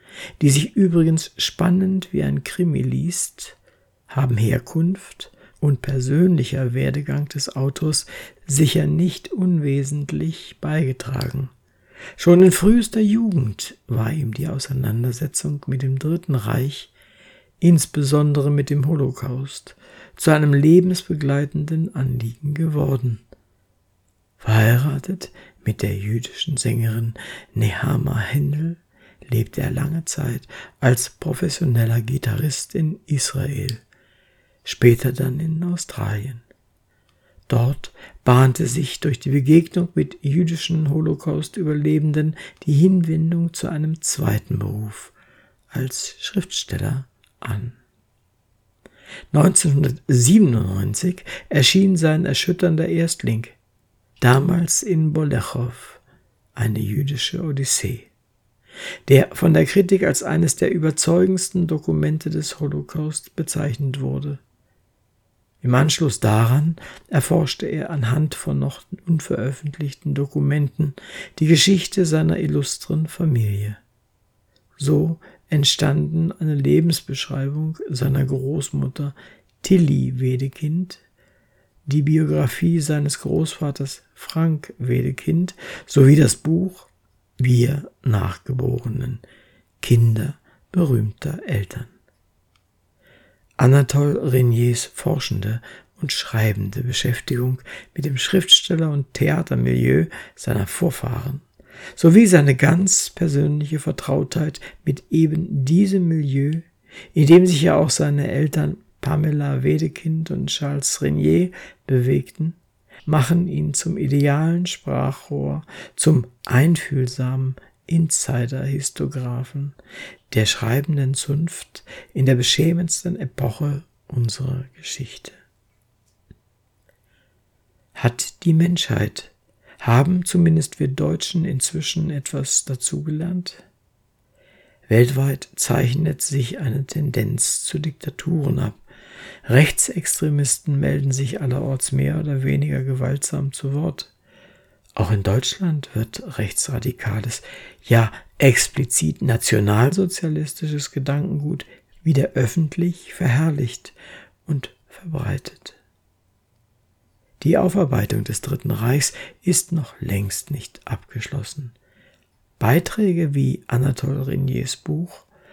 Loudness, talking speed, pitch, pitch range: -20 LUFS, 90 wpm, 140 Hz, 120-160 Hz